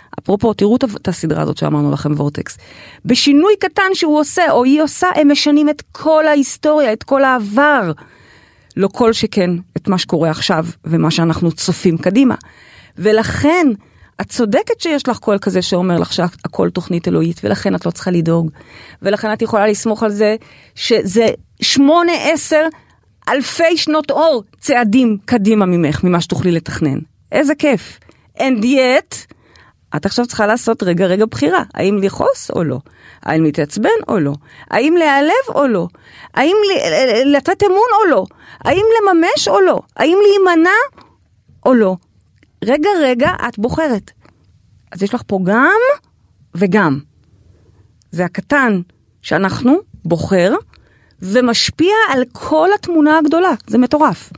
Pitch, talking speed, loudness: 225 Hz, 140 wpm, -14 LUFS